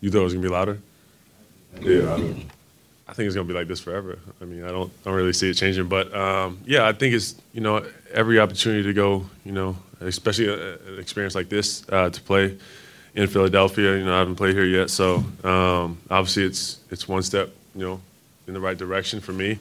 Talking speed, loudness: 235 wpm, -23 LUFS